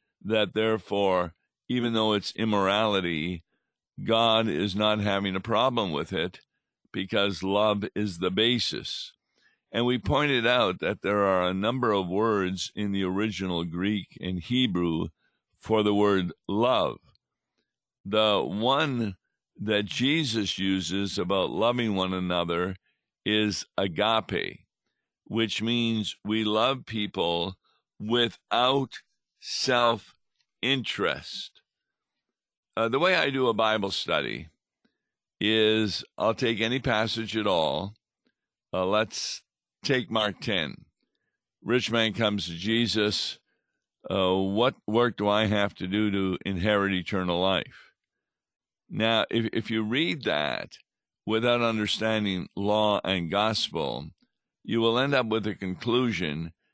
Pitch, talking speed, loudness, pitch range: 105 Hz, 120 wpm, -26 LUFS, 95-115 Hz